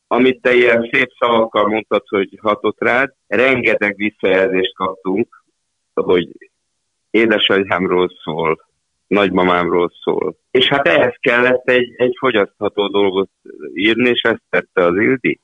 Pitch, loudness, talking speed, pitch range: 105 Hz, -15 LUFS, 120 wpm, 95-120 Hz